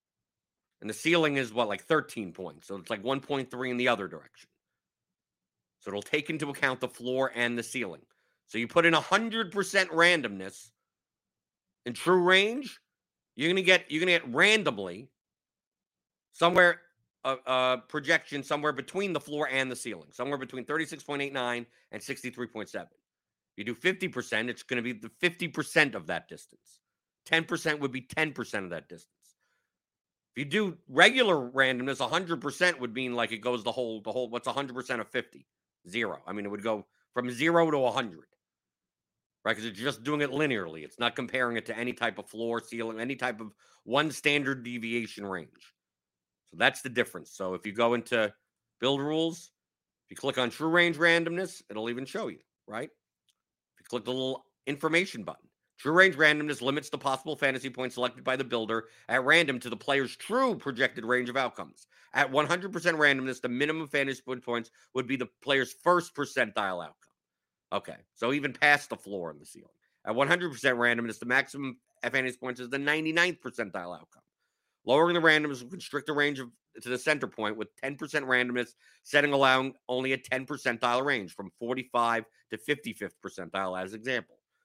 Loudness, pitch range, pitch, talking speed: -29 LUFS, 120-155 Hz, 130 Hz, 185 wpm